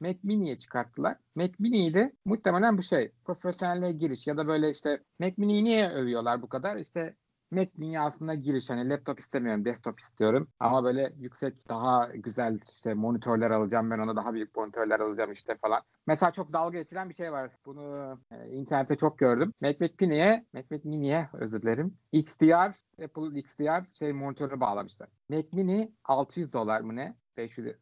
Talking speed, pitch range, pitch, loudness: 175 wpm, 120-175 Hz, 145 Hz, -29 LUFS